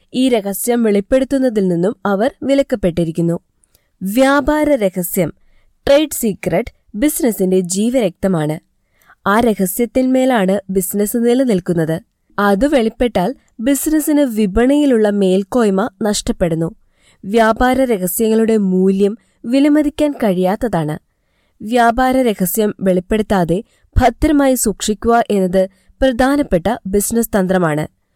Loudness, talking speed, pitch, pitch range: -15 LUFS, 75 wpm, 215 Hz, 190-255 Hz